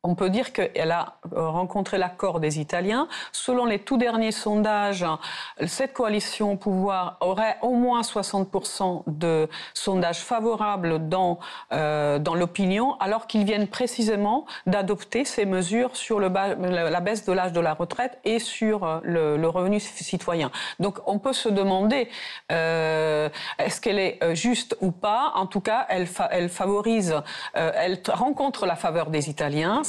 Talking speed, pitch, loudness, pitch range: 155 wpm, 195 Hz, -25 LUFS, 175-225 Hz